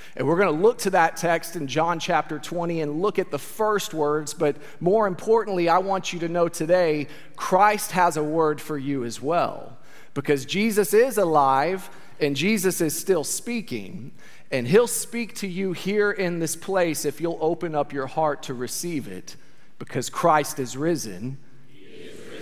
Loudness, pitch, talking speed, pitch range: -23 LUFS, 170 Hz, 175 wpm, 150-195 Hz